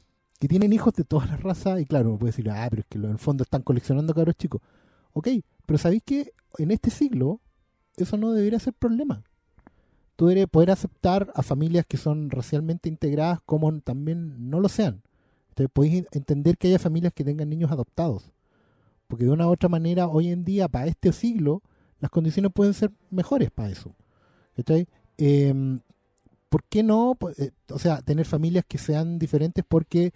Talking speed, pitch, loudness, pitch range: 185 wpm, 160 Hz, -24 LUFS, 140-180 Hz